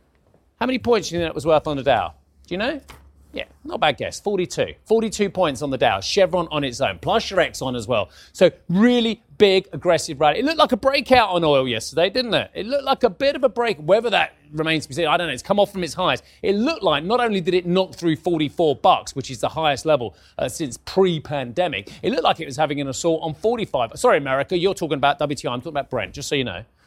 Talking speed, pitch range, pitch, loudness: 260 wpm, 145-205 Hz, 170 Hz, -21 LUFS